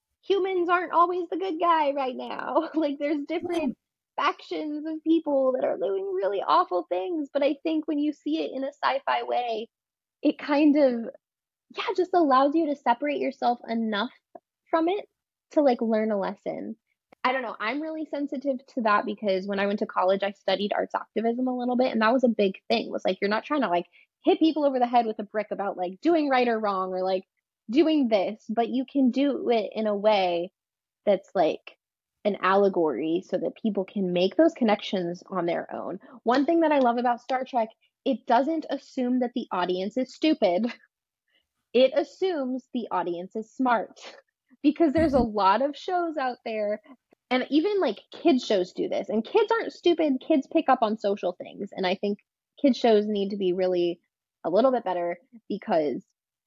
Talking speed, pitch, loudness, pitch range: 200 wpm, 250 Hz, -26 LUFS, 205-300 Hz